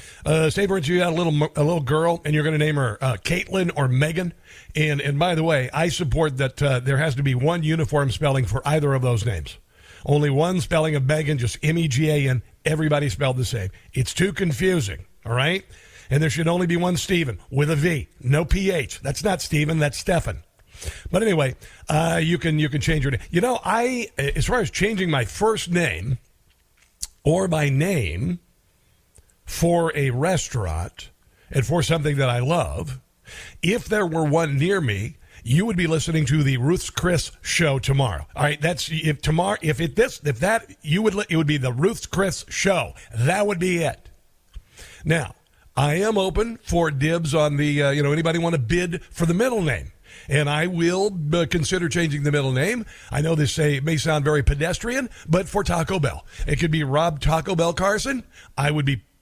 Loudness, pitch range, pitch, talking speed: -22 LUFS, 135-170 Hz, 155 Hz, 205 wpm